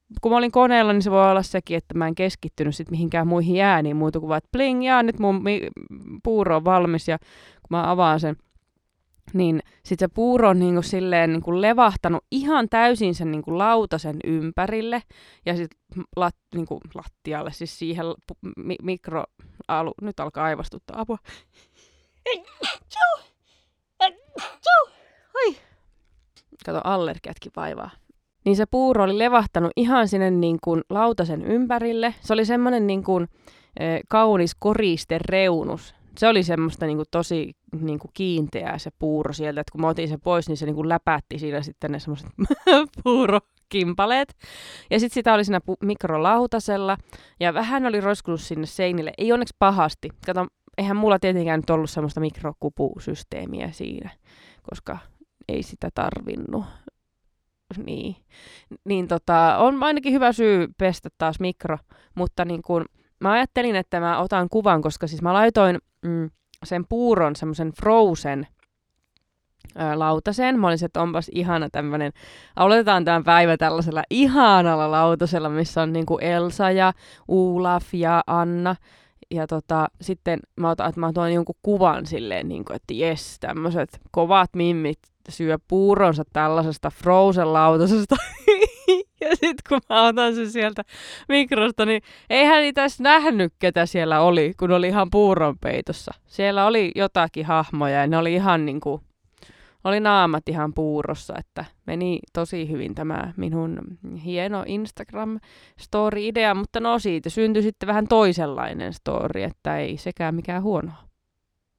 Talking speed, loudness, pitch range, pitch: 145 wpm, -21 LUFS, 160-215 Hz, 180 Hz